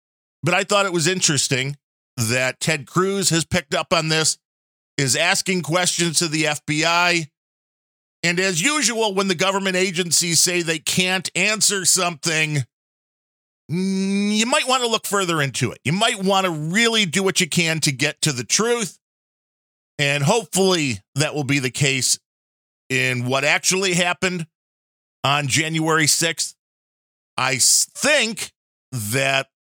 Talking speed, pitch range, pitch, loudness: 145 wpm, 140-185 Hz, 165 Hz, -19 LUFS